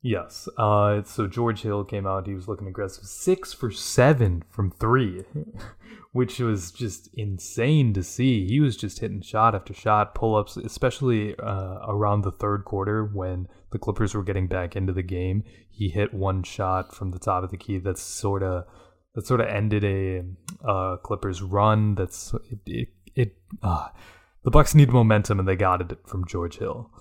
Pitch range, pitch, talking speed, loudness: 95-115 Hz, 100 Hz, 180 wpm, -25 LUFS